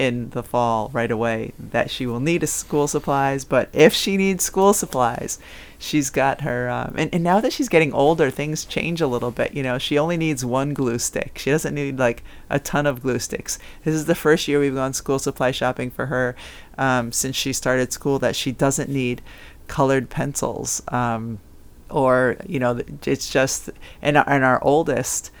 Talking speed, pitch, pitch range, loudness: 195 wpm, 135 Hz, 125-150 Hz, -21 LUFS